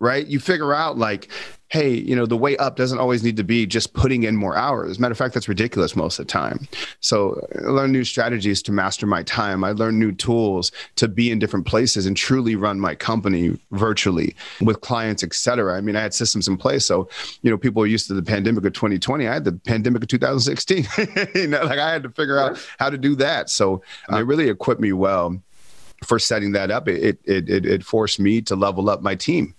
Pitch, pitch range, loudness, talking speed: 110 Hz, 100-130 Hz, -20 LUFS, 240 wpm